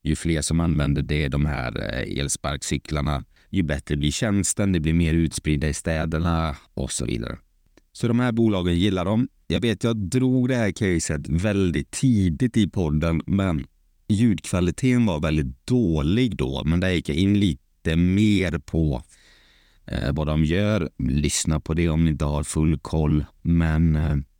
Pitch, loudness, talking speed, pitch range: 80 Hz, -23 LUFS, 165 wpm, 75-100 Hz